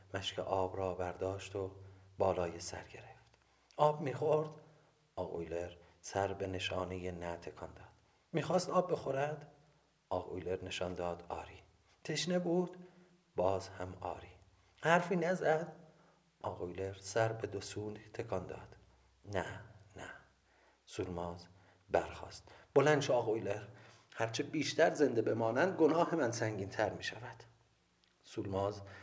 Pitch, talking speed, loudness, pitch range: 100 Hz, 115 wpm, -37 LUFS, 95-150 Hz